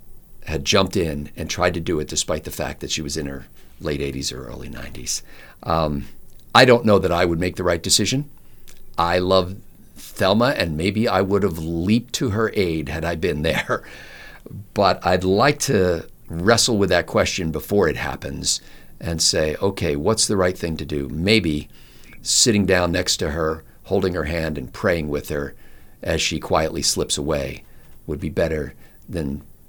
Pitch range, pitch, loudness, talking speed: 75-100 Hz, 85 Hz, -20 LUFS, 180 wpm